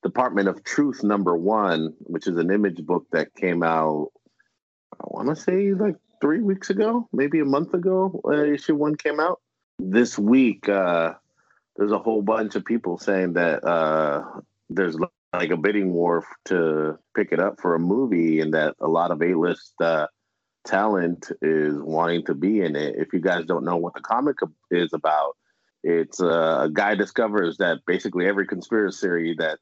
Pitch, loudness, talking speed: 100 Hz, -23 LUFS, 175 wpm